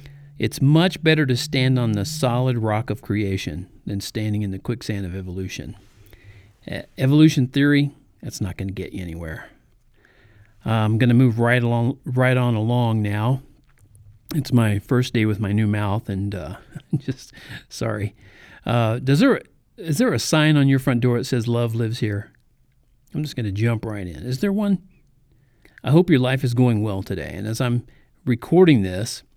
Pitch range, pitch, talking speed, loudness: 105-130 Hz, 120 Hz, 180 wpm, -21 LUFS